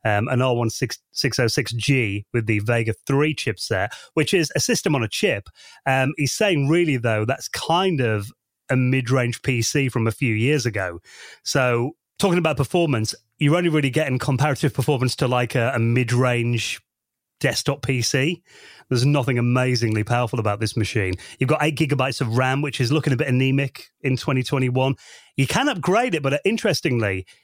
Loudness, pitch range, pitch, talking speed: -21 LUFS, 120-145 Hz, 130 Hz, 170 wpm